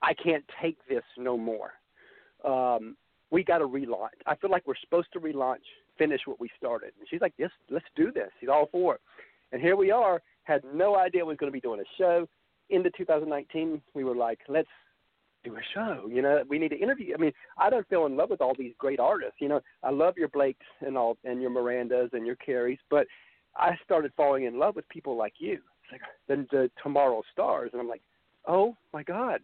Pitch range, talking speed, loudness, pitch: 130-175 Hz, 230 wpm, -29 LUFS, 145 Hz